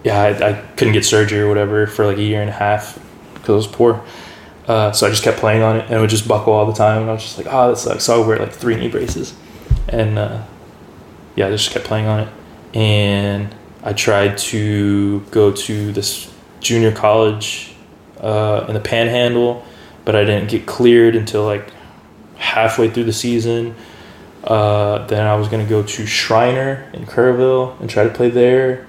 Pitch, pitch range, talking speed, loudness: 110 Hz, 105-115 Hz, 210 wpm, -16 LUFS